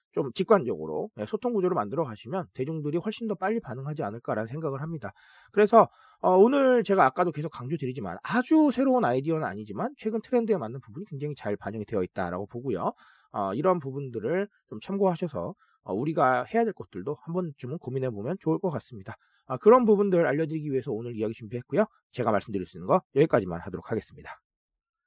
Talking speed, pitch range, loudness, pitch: 440 characters per minute, 130-205 Hz, -27 LUFS, 165 Hz